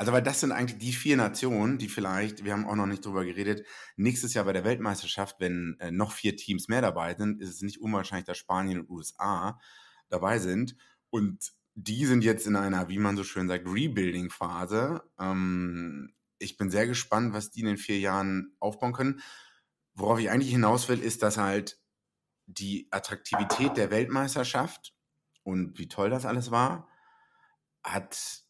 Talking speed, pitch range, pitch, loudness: 175 wpm, 95-120 Hz, 105 Hz, -30 LUFS